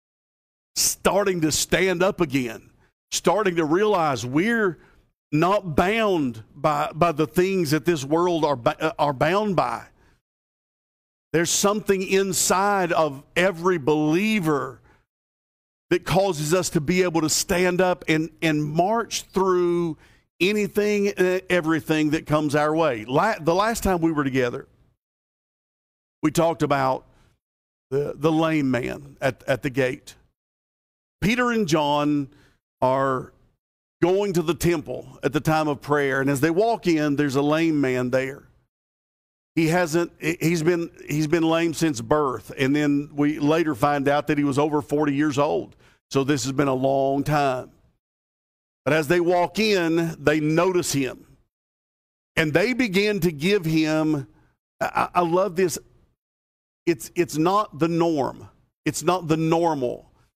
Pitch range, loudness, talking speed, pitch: 145-180 Hz, -22 LUFS, 145 wpm, 160 Hz